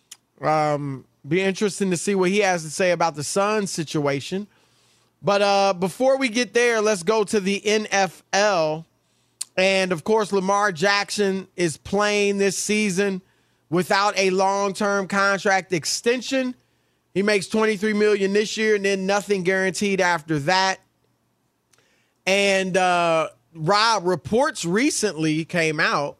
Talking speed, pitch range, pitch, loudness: 135 wpm, 180-210 Hz, 195 Hz, -21 LUFS